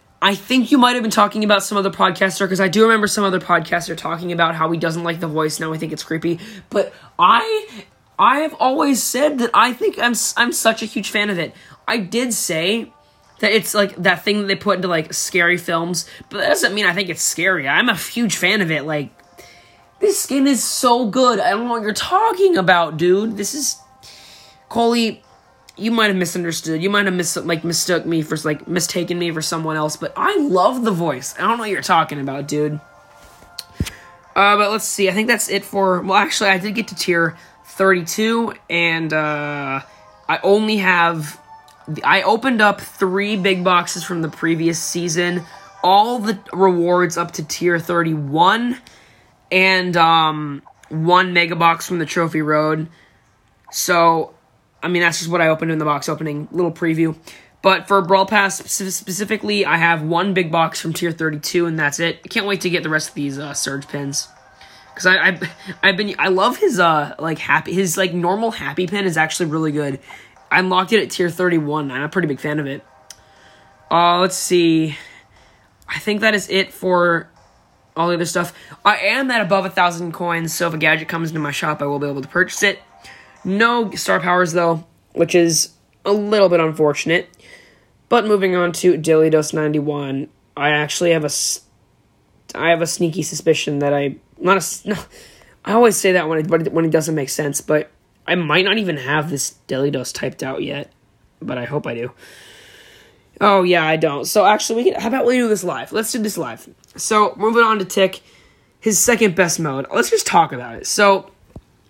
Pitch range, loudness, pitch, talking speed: 160-205 Hz, -17 LUFS, 175 Hz, 200 wpm